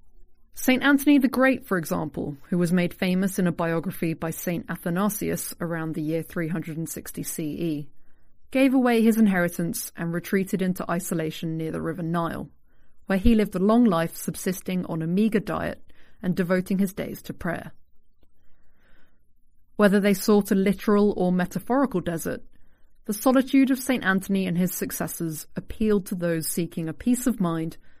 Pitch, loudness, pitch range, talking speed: 180 Hz, -25 LUFS, 165-210 Hz, 160 wpm